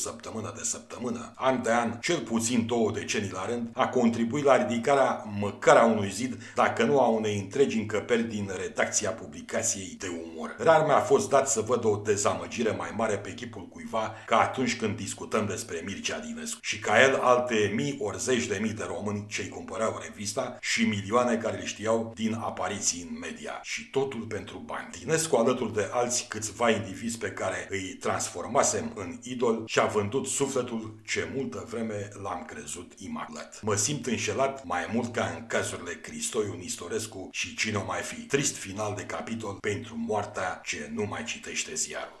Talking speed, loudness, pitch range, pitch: 180 wpm, -28 LUFS, 105-125 Hz, 115 Hz